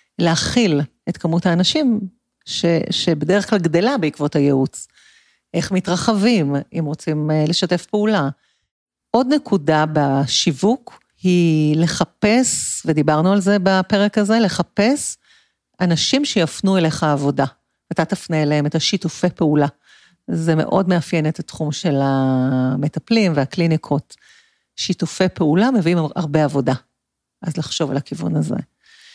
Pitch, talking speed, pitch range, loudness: 170 Hz, 115 wpm, 155-200 Hz, -18 LUFS